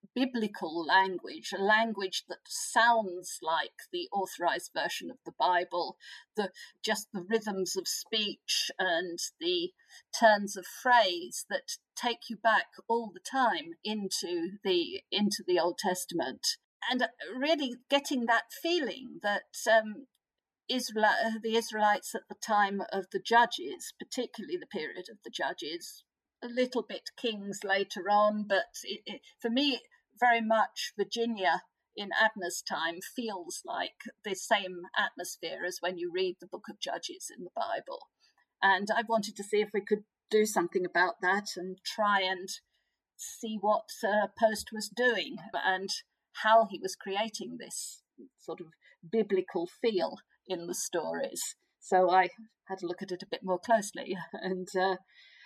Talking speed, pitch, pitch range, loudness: 150 wpm, 215 Hz, 190-250 Hz, -31 LUFS